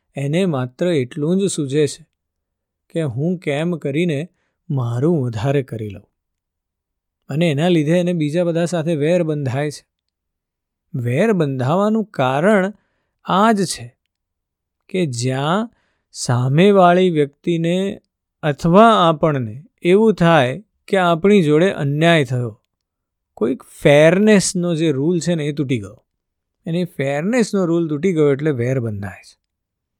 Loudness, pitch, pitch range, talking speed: -17 LUFS, 150 Hz, 120-175 Hz, 120 wpm